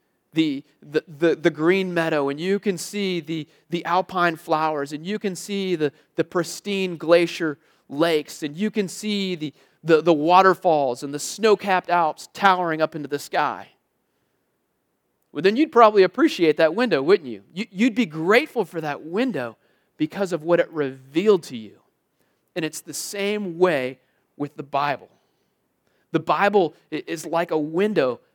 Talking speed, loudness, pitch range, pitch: 165 wpm, -22 LUFS, 155-200 Hz, 170 Hz